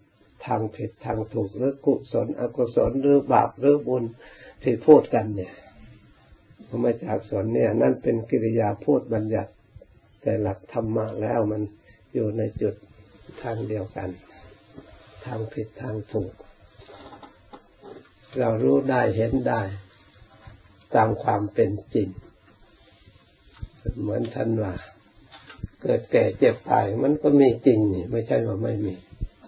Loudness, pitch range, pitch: -24 LUFS, 105-120 Hz, 110 Hz